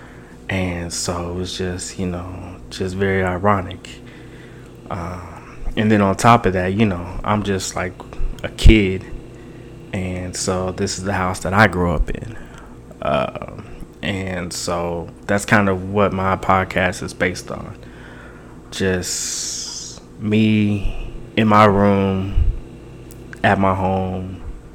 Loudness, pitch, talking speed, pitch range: -19 LUFS, 95 Hz, 135 wpm, 90-105 Hz